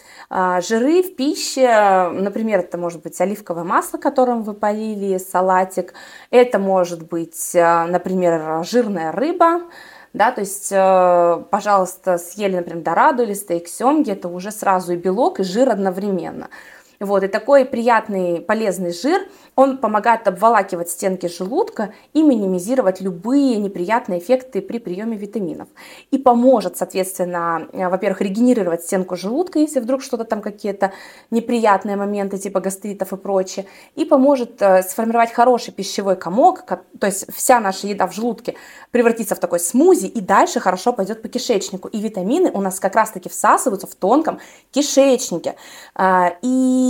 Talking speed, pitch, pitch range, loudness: 140 wpm, 200 Hz, 185-245 Hz, -18 LUFS